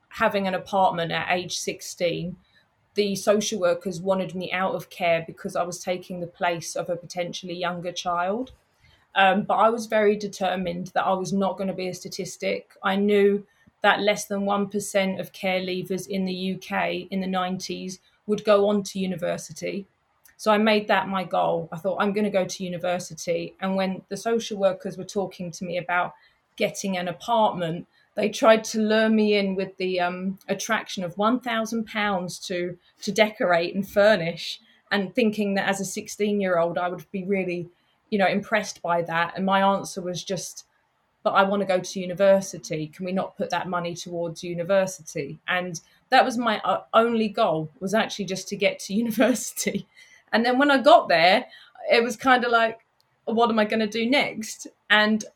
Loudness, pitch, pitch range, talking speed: -24 LUFS, 190 Hz, 180-210 Hz, 185 wpm